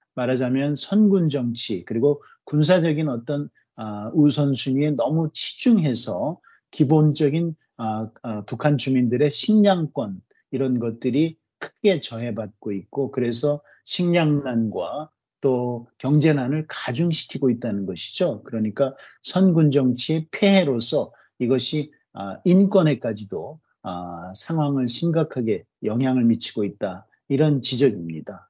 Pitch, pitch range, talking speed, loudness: 135 Hz, 120-155 Hz, 255 characters per minute, -22 LUFS